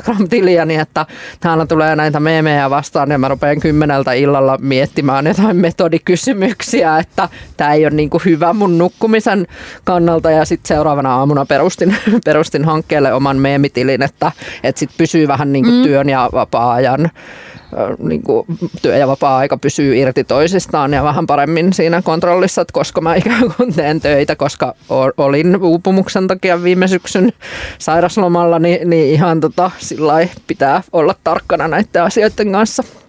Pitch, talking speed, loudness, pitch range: 165 Hz, 140 wpm, -13 LUFS, 145-180 Hz